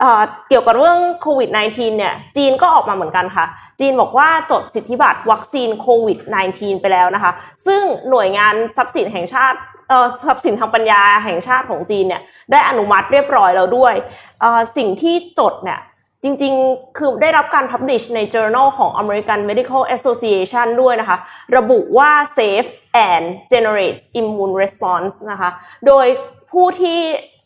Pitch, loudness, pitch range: 245 Hz, -14 LUFS, 205-275 Hz